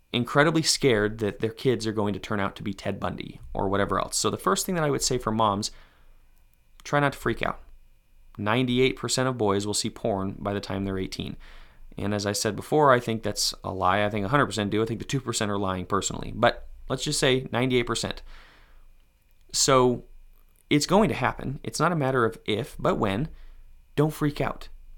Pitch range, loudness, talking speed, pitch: 100-130 Hz, -26 LUFS, 205 wpm, 110 Hz